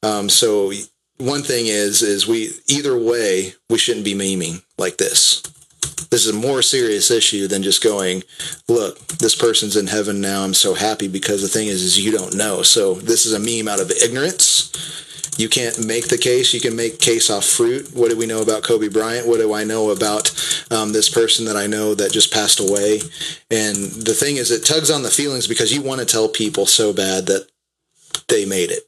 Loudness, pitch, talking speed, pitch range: -16 LUFS, 110 Hz, 215 wpm, 100-120 Hz